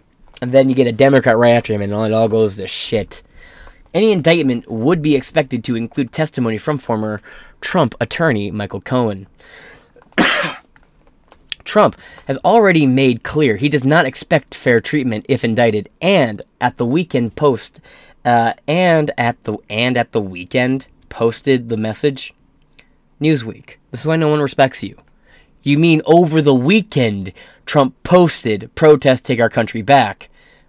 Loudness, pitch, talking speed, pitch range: -15 LUFS, 130 Hz, 155 wpm, 115-150 Hz